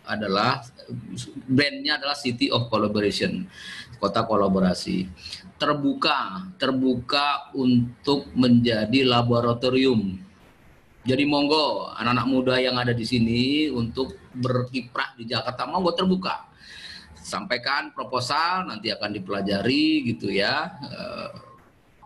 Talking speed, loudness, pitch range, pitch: 95 wpm, -23 LUFS, 110-135 Hz, 125 Hz